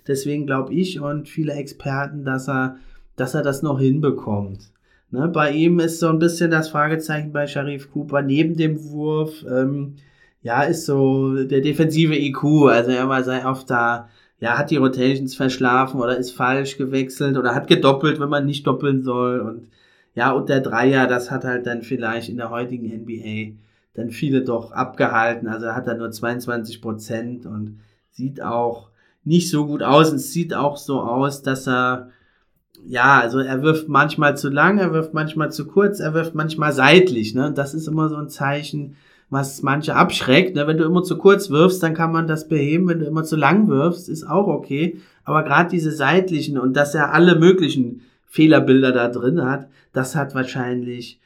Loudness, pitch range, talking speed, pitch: -19 LUFS, 125-155 Hz, 185 wpm, 140 Hz